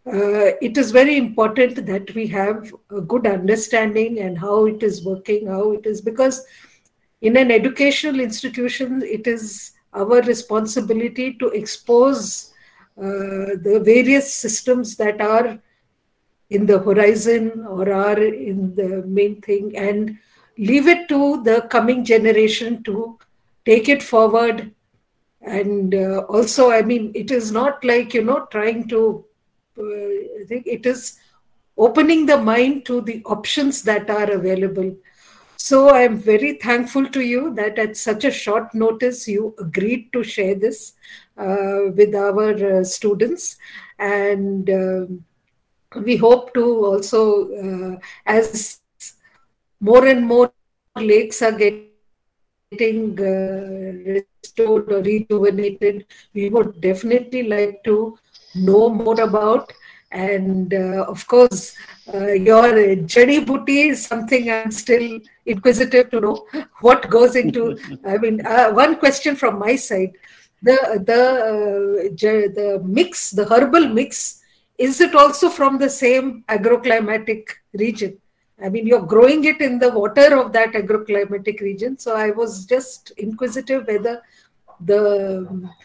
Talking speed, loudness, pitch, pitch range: 135 wpm, -17 LUFS, 220 Hz, 205-250 Hz